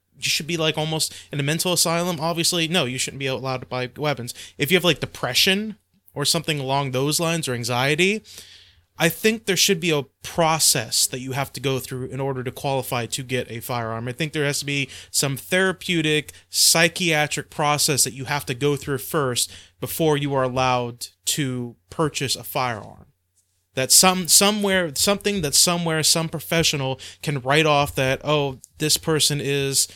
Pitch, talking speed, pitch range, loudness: 145 Hz, 185 wpm, 130-165 Hz, -21 LUFS